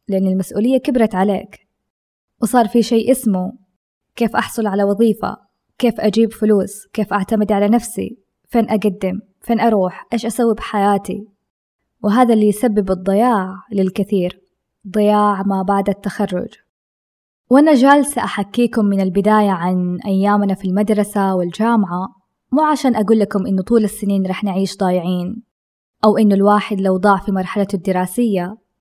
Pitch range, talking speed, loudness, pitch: 195-225 Hz, 130 wpm, -16 LUFS, 205 Hz